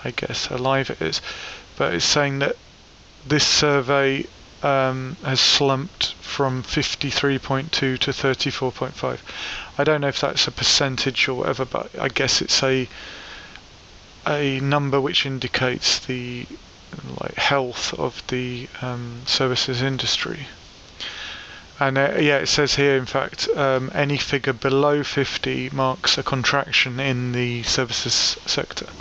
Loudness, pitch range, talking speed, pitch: -21 LUFS, 130-140 Hz, 130 wpm, 135 Hz